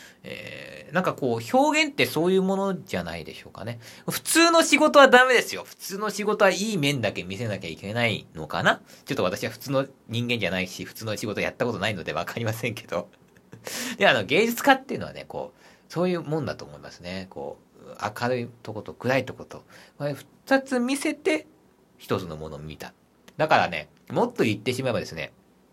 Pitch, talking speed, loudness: 125 Hz, 400 characters per minute, -24 LUFS